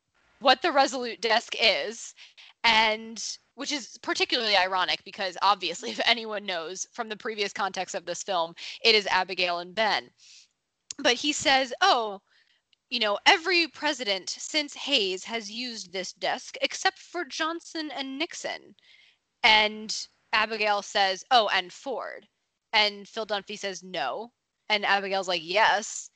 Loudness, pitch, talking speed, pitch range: -26 LUFS, 220 Hz, 140 wpm, 195-270 Hz